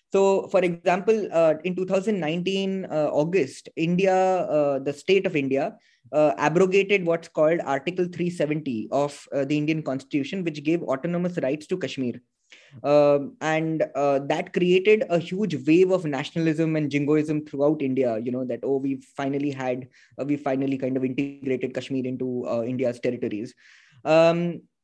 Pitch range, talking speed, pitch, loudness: 135-175 Hz, 155 wpm, 150 Hz, -24 LUFS